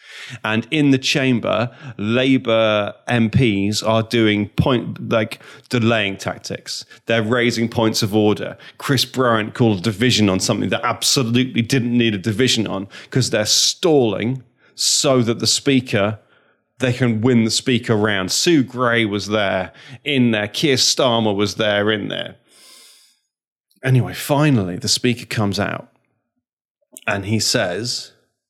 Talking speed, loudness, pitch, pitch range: 135 wpm, -18 LUFS, 115 Hz, 105-125 Hz